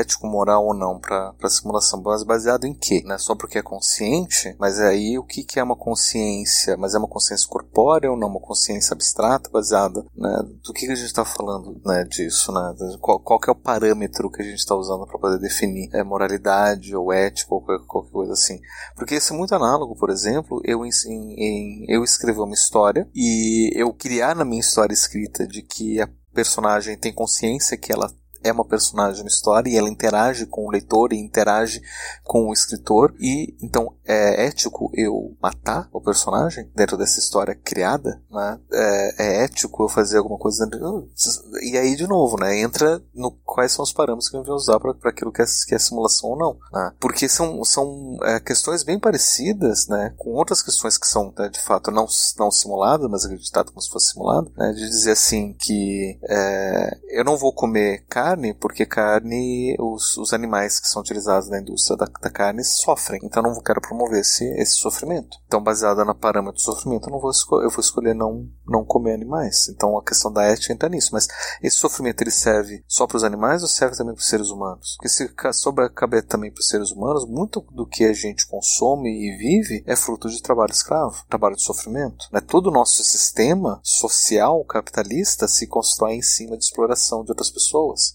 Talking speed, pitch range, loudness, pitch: 205 wpm, 100-120 Hz, -20 LUFS, 110 Hz